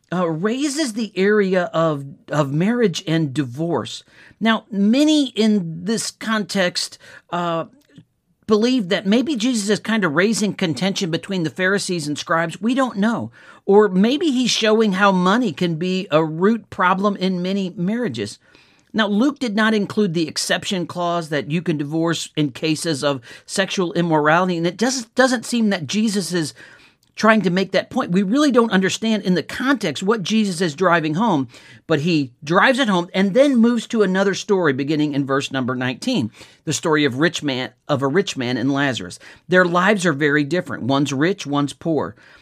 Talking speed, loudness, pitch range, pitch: 175 wpm, -19 LUFS, 160-215 Hz, 185 Hz